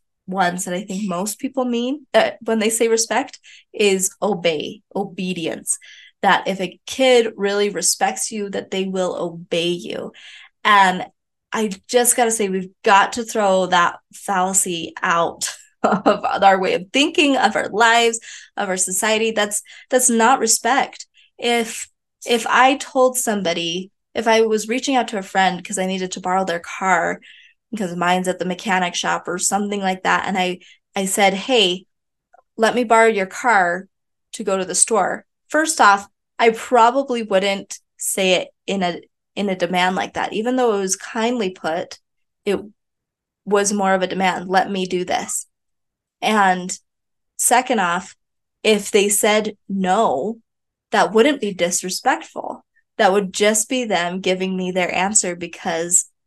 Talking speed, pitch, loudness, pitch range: 160 wpm, 200 Hz, -18 LUFS, 185-230 Hz